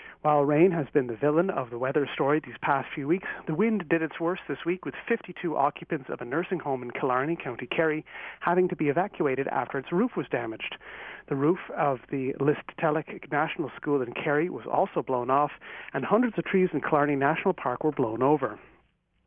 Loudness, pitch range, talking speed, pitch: -28 LUFS, 140-175 Hz, 200 wpm, 155 Hz